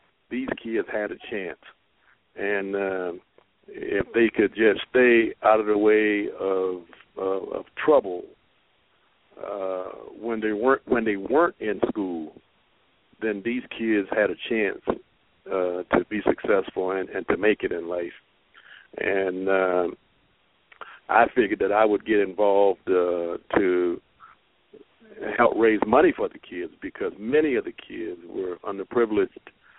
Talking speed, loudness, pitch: 140 wpm, -24 LUFS, 105 Hz